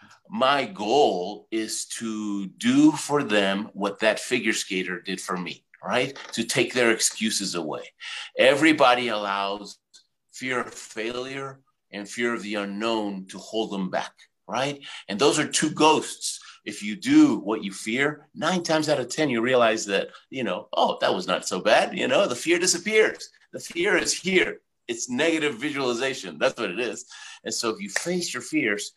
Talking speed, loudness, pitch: 175 wpm, -24 LUFS, 125 Hz